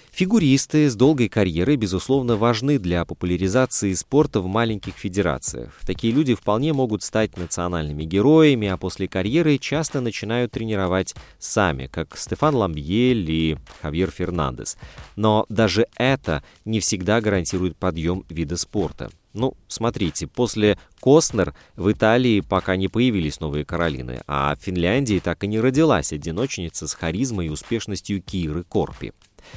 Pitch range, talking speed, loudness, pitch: 85-120 Hz, 135 wpm, -21 LUFS, 100 Hz